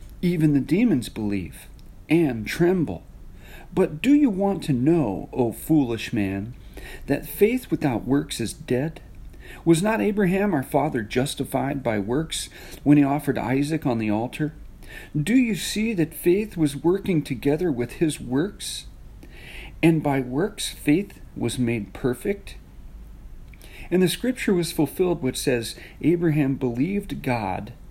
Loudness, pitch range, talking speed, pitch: -23 LUFS, 120-170 Hz, 140 wpm, 145 Hz